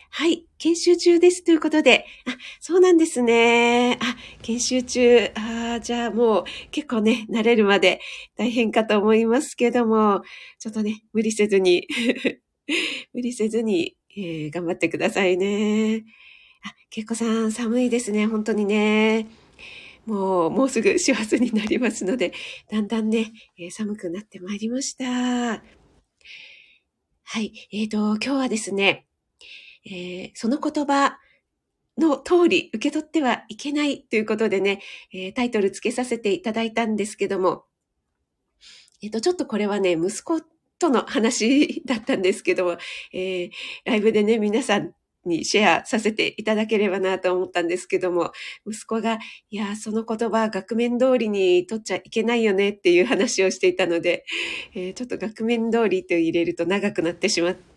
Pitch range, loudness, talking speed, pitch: 200-250 Hz, -22 LUFS, 305 characters per minute, 225 Hz